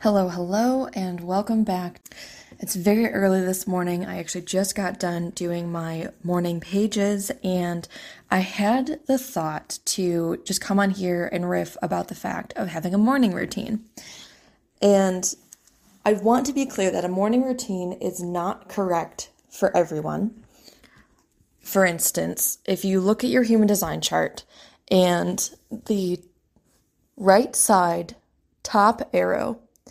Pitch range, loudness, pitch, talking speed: 175-215 Hz, -23 LUFS, 190 Hz, 140 wpm